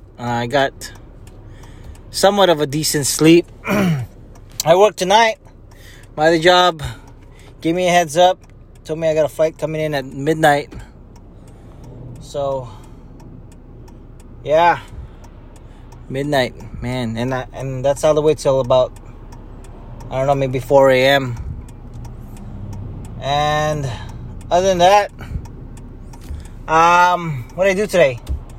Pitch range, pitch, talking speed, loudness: 115-155 Hz, 130 Hz, 120 wpm, -16 LUFS